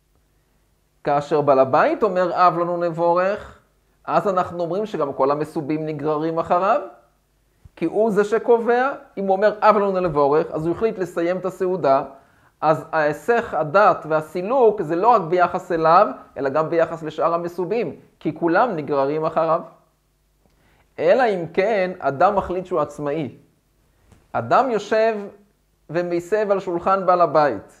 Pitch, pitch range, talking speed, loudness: 175 Hz, 155-195 Hz, 135 wpm, -20 LUFS